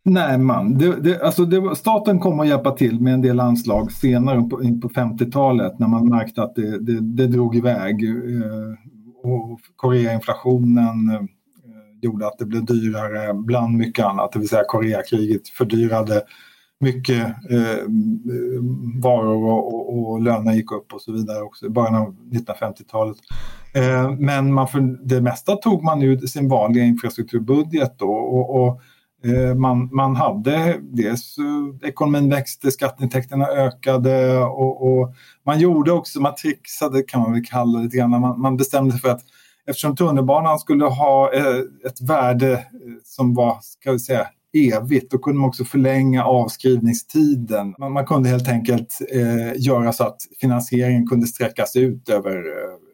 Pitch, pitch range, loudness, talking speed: 125 Hz, 115-135 Hz, -19 LUFS, 155 wpm